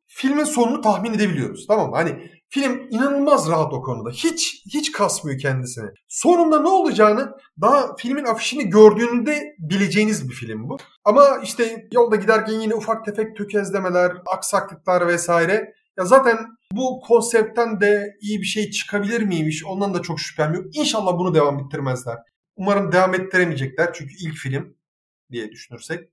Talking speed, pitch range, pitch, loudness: 145 wpm, 170-235 Hz, 205 Hz, -19 LUFS